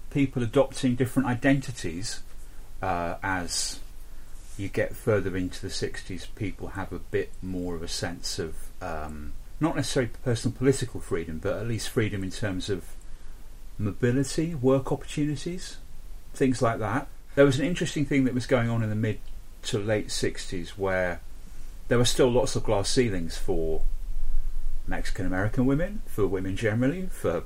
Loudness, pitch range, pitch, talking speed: -28 LUFS, 90-135 Hz, 105 Hz, 155 wpm